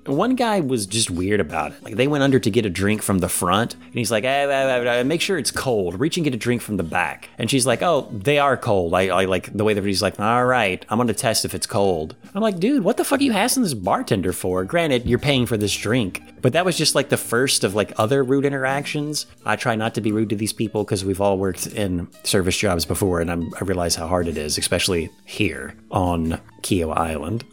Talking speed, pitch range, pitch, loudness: 260 wpm, 95-135 Hz, 110 Hz, -21 LUFS